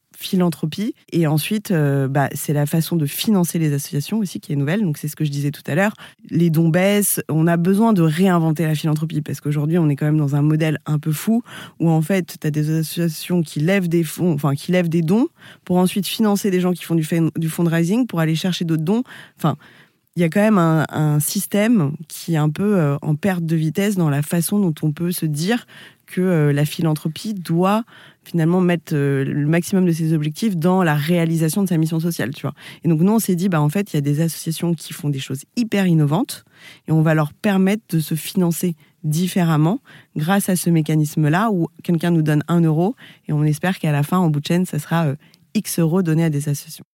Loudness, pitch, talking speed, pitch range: -19 LUFS, 165 Hz, 230 wpm, 155-185 Hz